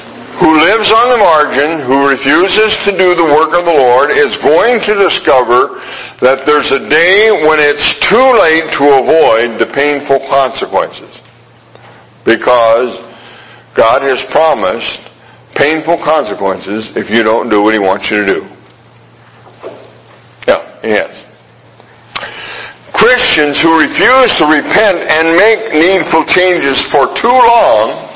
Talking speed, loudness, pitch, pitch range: 130 wpm, -9 LUFS, 150 Hz, 125-180 Hz